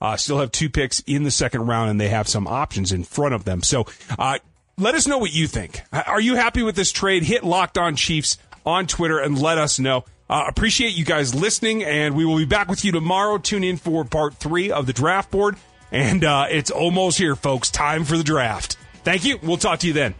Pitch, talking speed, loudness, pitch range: 160 Hz, 240 wpm, -20 LUFS, 135-185 Hz